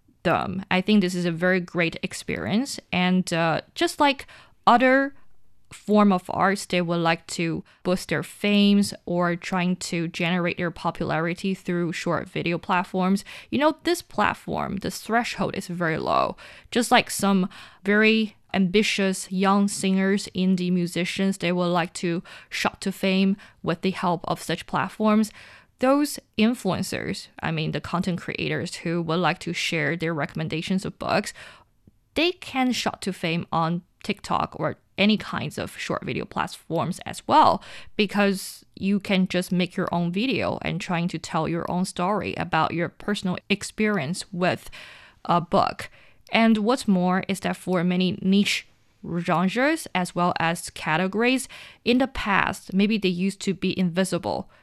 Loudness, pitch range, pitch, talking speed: -24 LUFS, 175-205 Hz, 185 Hz, 155 wpm